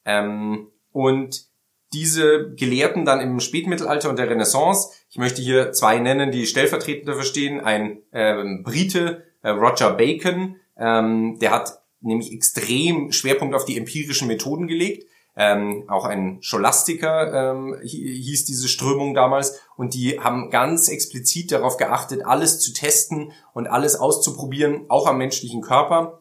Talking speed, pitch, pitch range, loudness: 140 wpm, 135 Hz, 115-150 Hz, -20 LUFS